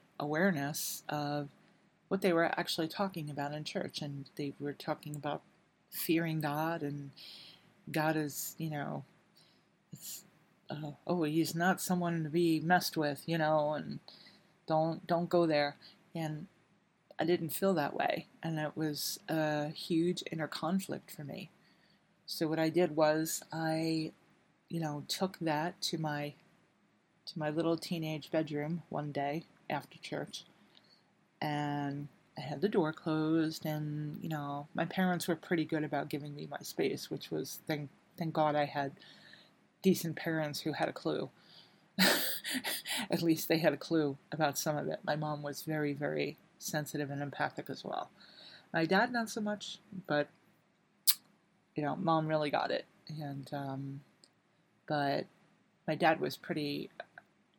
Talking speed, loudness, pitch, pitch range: 150 wpm, -35 LUFS, 160 Hz, 150-180 Hz